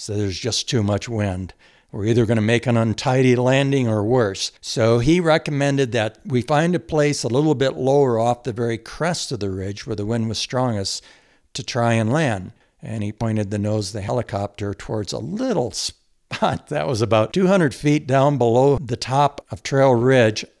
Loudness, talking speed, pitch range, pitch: -20 LUFS, 200 wpm, 110-135 Hz, 120 Hz